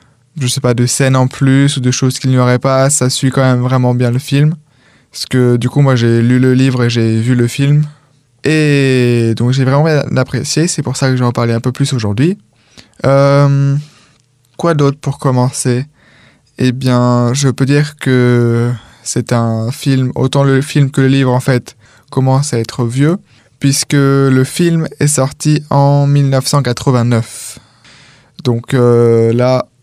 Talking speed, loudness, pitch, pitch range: 180 wpm, -12 LUFS, 130 Hz, 125-140 Hz